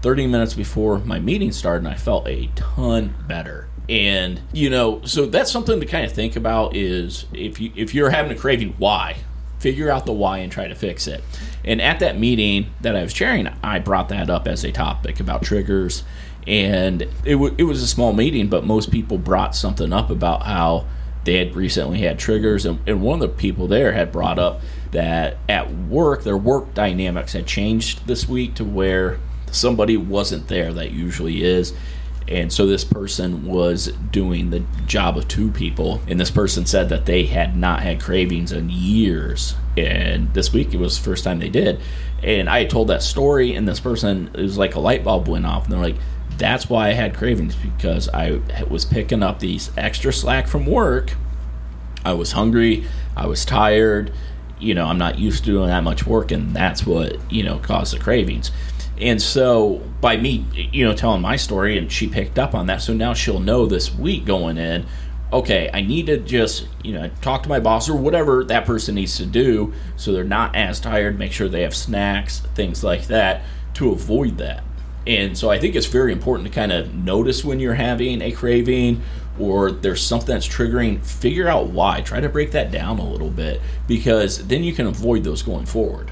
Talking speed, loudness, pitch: 205 wpm, -20 LUFS, 90 Hz